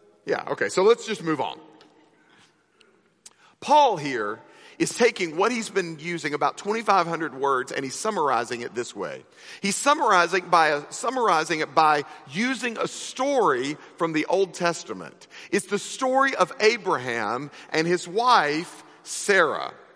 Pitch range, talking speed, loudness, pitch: 160-260 Hz, 140 wpm, -24 LUFS, 195 Hz